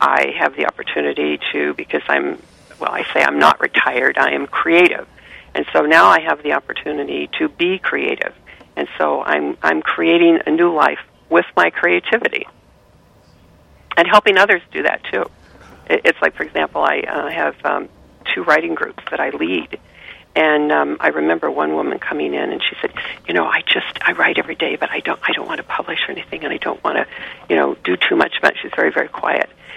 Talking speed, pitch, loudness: 205 wpm, 155 Hz, -16 LUFS